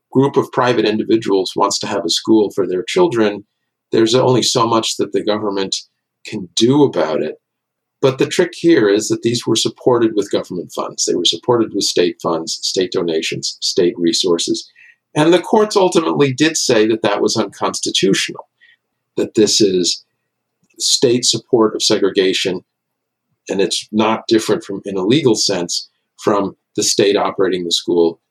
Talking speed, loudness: 165 wpm, -15 LUFS